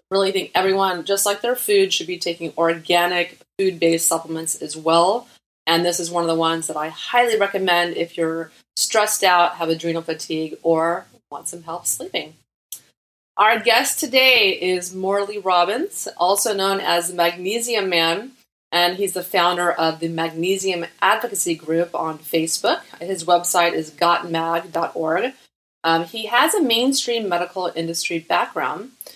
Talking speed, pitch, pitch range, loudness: 150 wpm, 175 Hz, 165-195 Hz, -20 LUFS